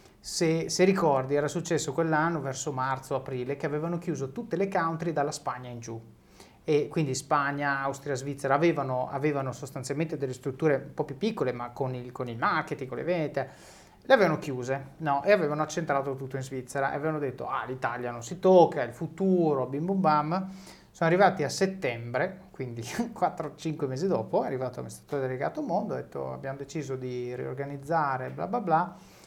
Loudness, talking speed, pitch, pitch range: -29 LUFS, 180 wpm, 145 Hz, 135-165 Hz